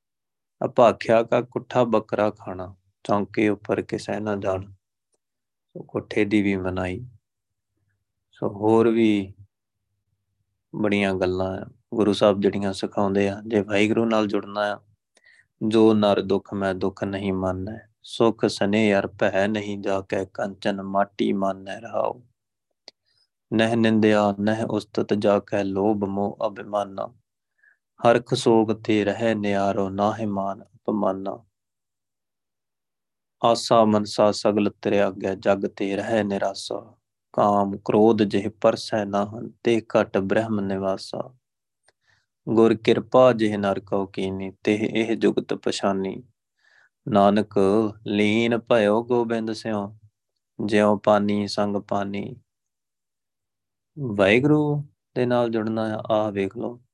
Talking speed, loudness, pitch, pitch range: 115 wpm, -23 LUFS, 105 Hz, 100-110 Hz